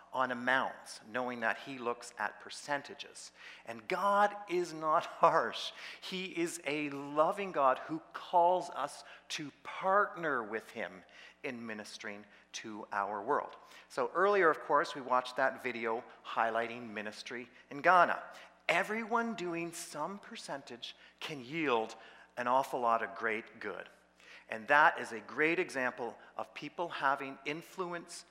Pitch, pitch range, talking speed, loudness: 135 Hz, 115-170 Hz, 135 wpm, -34 LUFS